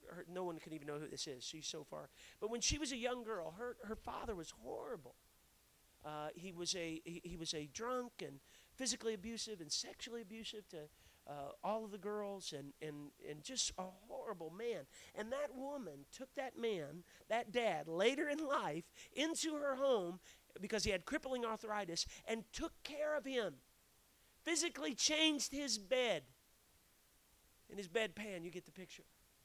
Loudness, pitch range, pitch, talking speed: -43 LUFS, 175-260 Hz, 215 Hz, 175 wpm